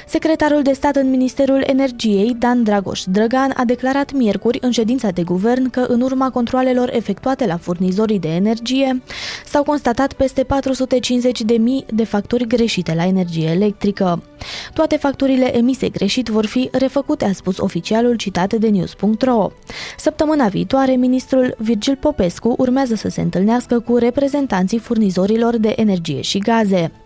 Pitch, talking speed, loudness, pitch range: 240 Hz, 145 wpm, -17 LUFS, 205-265 Hz